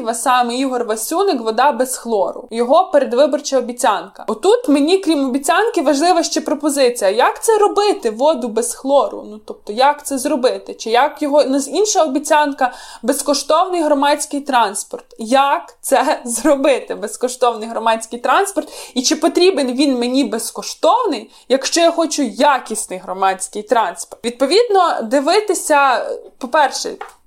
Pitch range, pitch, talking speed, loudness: 245-320 Hz, 285 Hz, 125 wpm, -16 LUFS